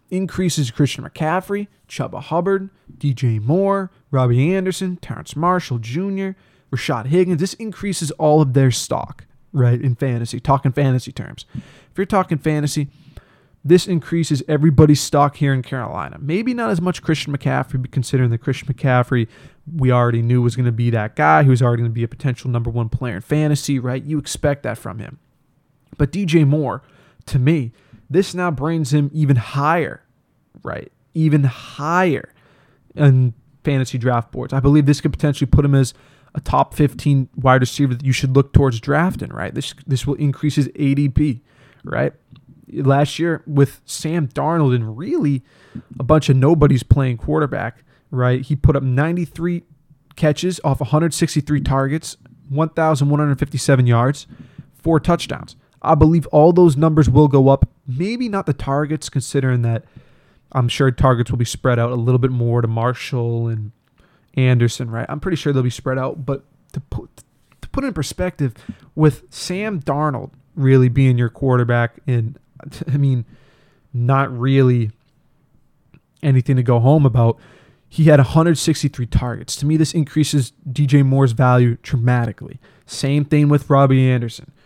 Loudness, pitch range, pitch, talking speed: -18 LUFS, 125-155 Hz, 140 Hz, 160 wpm